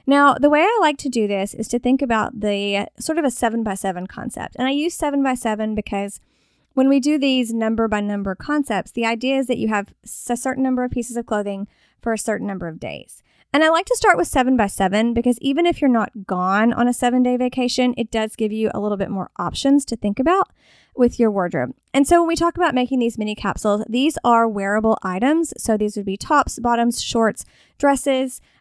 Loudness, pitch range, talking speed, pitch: -20 LUFS, 210-270 Hz, 235 wpm, 235 Hz